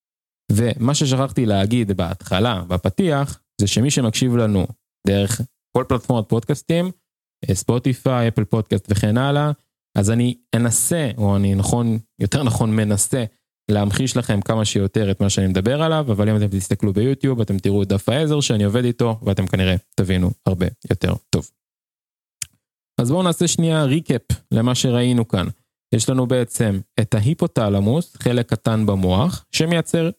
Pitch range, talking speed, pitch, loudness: 100-130 Hz, 140 wpm, 115 Hz, -19 LUFS